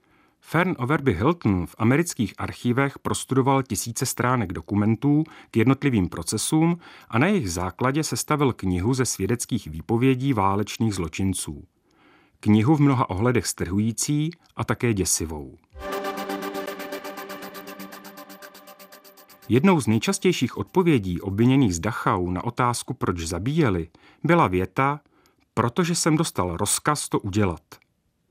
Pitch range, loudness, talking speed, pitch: 95-140 Hz, -23 LUFS, 110 wpm, 115 Hz